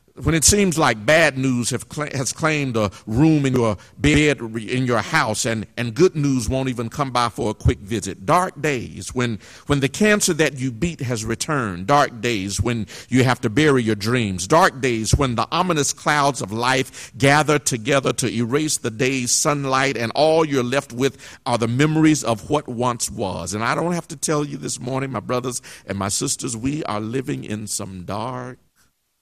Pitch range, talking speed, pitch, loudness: 115-145 Hz, 200 wpm, 130 Hz, -20 LUFS